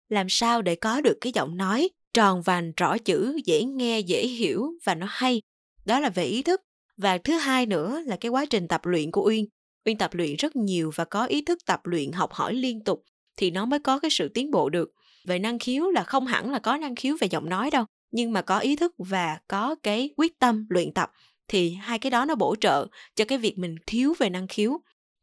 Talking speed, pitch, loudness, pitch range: 240 wpm, 225 Hz, -26 LUFS, 185-265 Hz